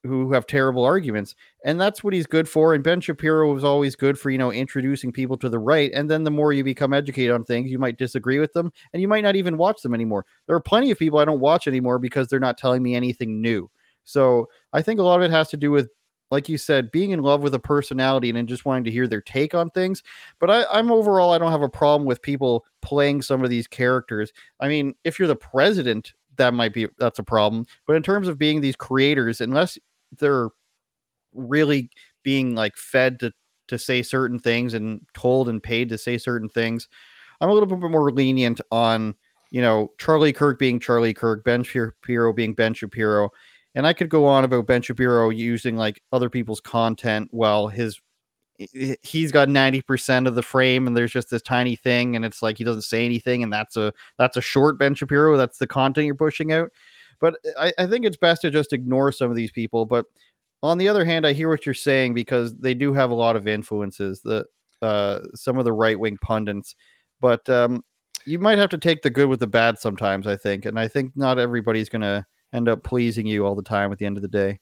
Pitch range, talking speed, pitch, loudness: 115-145 Hz, 230 wpm, 130 Hz, -21 LUFS